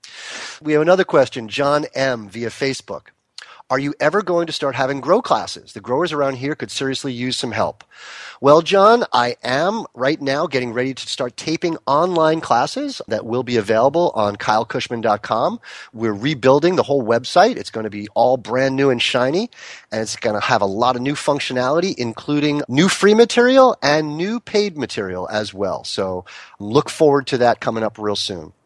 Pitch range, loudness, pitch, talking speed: 115-155 Hz, -18 LUFS, 135 Hz, 185 wpm